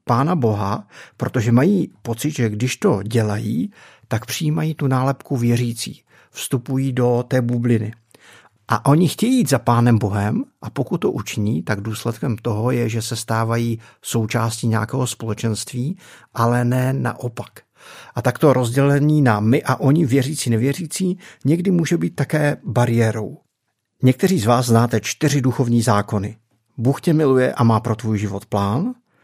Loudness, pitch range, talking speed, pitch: -19 LUFS, 115-140 Hz, 150 wpm, 120 Hz